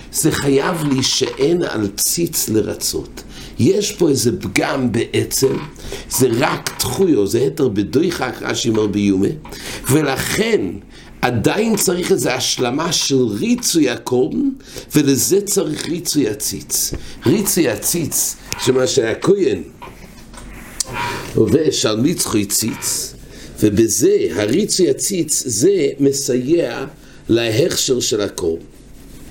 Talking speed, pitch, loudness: 100 wpm, 150 Hz, -17 LUFS